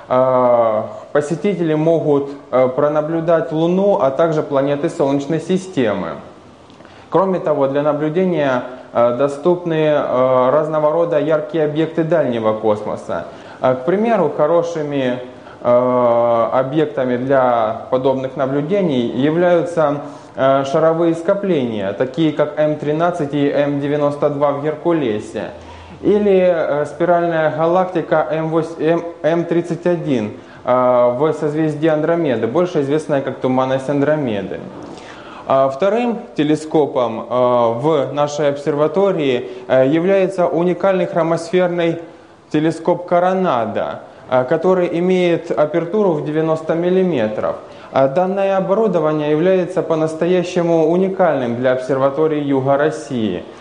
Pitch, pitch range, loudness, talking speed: 155 Hz, 135-170 Hz, -16 LUFS, 85 wpm